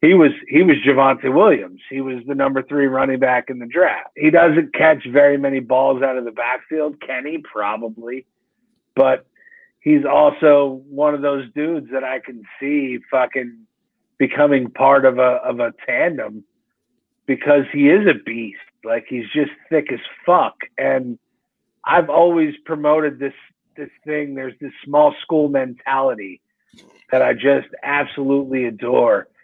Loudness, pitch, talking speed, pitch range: -17 LUFS, 140 Hz, 155 wpm, 130-150 Hz